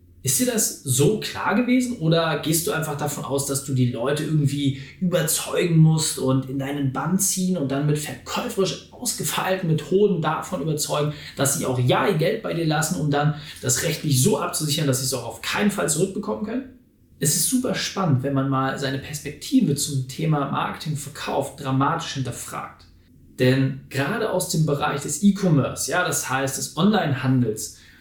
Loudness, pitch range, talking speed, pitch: -22 LUFS, 135-180 Hz, 180 wpm, 150 Hz